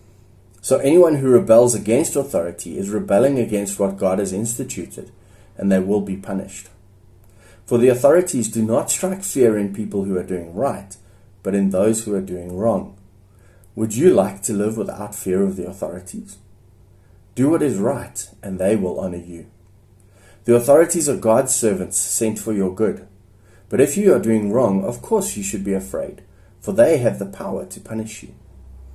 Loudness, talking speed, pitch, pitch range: -19 LUFS, 180 wpm, 100 Hz, 95-115 Hz